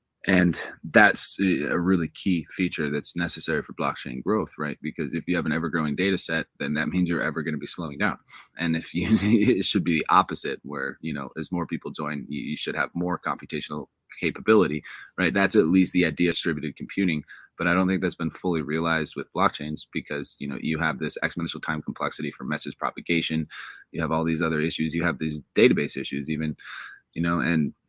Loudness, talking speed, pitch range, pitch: -25 LUFS, 210 wpm, 80-90 Hz, 85 Hz